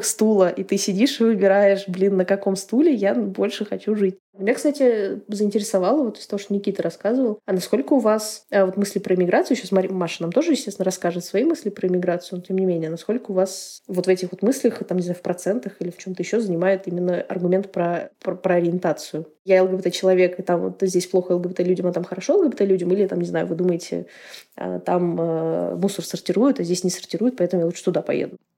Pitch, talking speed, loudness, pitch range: 190 Hz, 205 wpm, -22 LUFS, 180-205 Hz